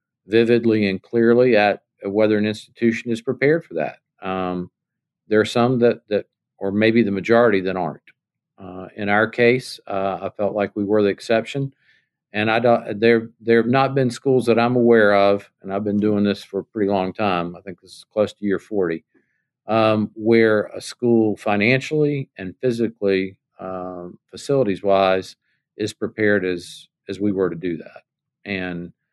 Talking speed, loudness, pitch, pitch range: 175 wpm, -20 LUFS, 105 Hz, 100-120 Hz